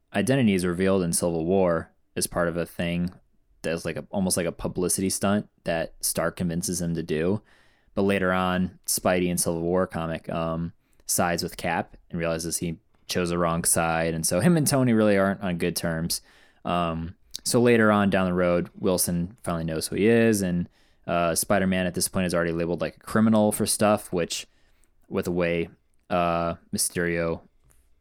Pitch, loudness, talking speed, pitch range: 85 Hz, -25 LUFS, 185 wpm, 85-95 Hz